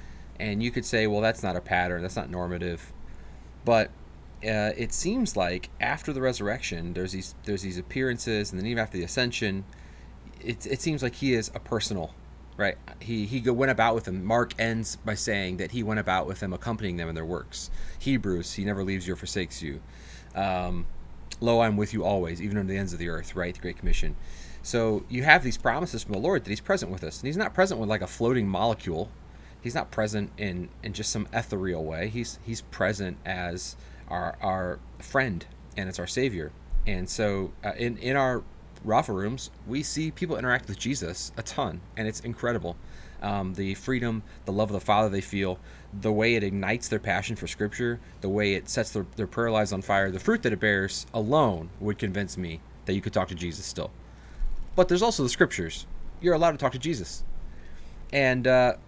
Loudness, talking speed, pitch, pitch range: -28 LUFS, 210 wpm, 100 Hz, 85-115 Hz